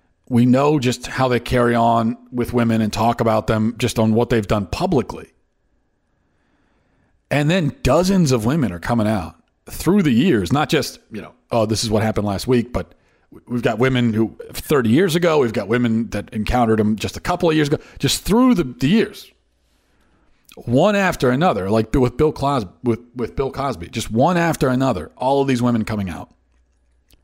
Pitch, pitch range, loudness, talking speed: 120 Hz, 110-130 Hz, -18 LUFS, 190 wpm